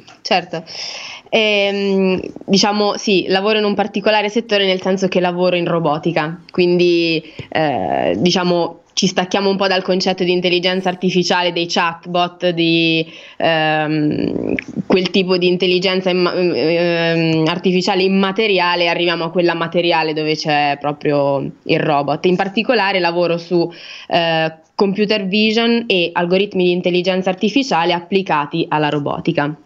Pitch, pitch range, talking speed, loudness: 180 Hz, 165-195 Hz, 130 wpm, -16 LUFS